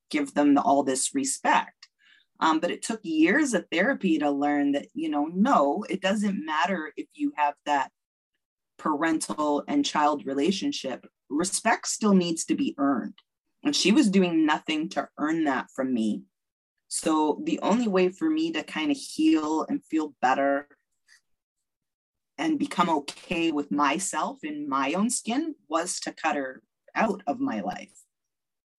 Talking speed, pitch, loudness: 155 wpm, 195 Hz, -26 LUFS